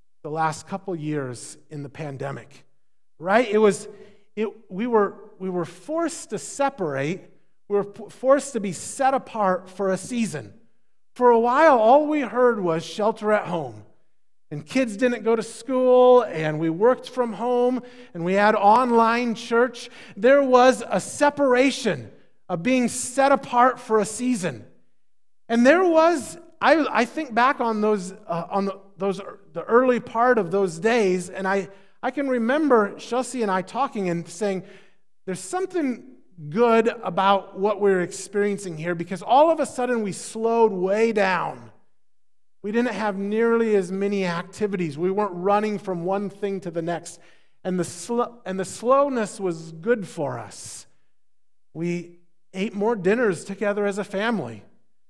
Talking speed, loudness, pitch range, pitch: 160 wpm, -22 LUFS, 185-245 Hz, 210 Hz